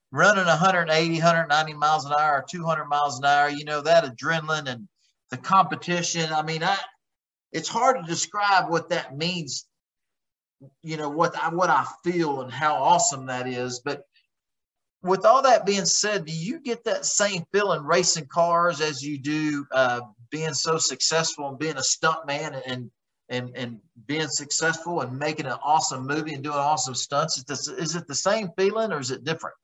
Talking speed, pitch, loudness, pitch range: 185 wpm, 155 Hz, -24 LUFS, 140-175 Hz